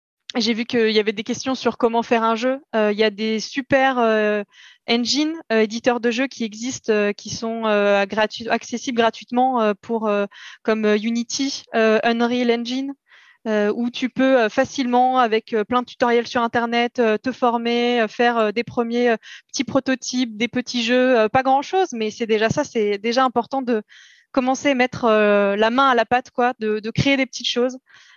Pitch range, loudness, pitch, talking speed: 220-255 Hz, -20 LUFS, 235 Hz, 200 wpm